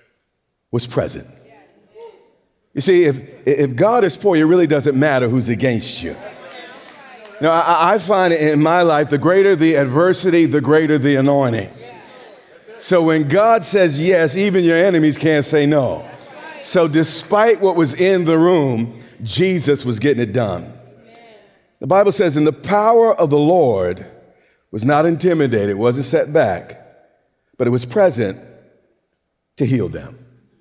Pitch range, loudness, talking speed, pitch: 135-185 Hz, -15 LUFS, 150 wpm, 155 Hz